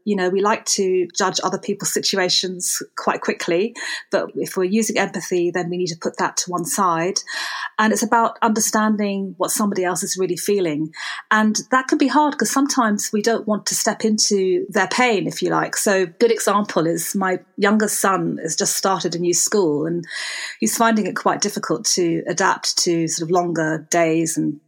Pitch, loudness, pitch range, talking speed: 190 Hz, -19 LUFS, 175-215 Hz, 195 wpm